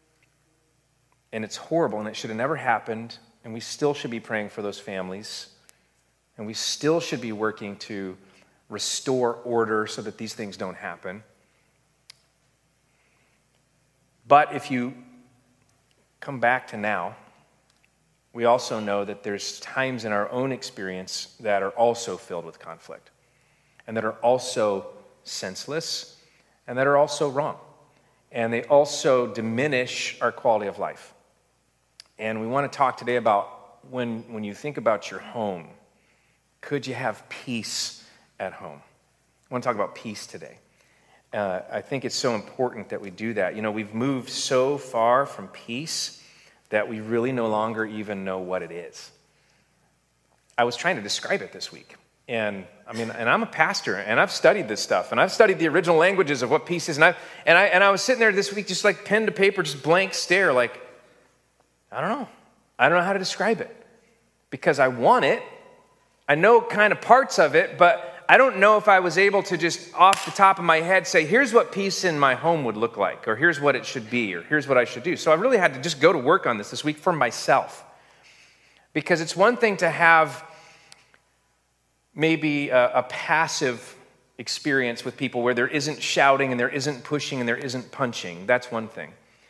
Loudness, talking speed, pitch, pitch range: -23 LUFS, 190 wpm, 125 Hz, 110-160 Hz